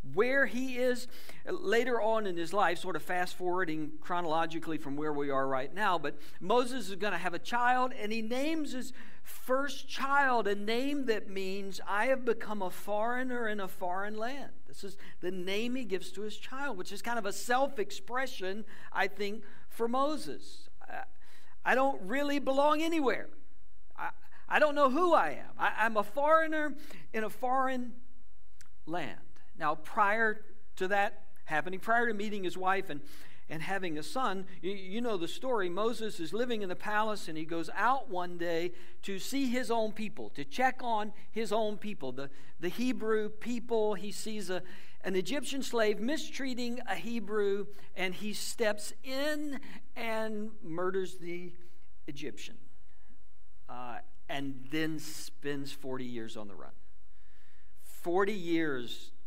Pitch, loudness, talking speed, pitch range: 210 Hz, -34 LUFS, 160 wpm, 180-245 Hz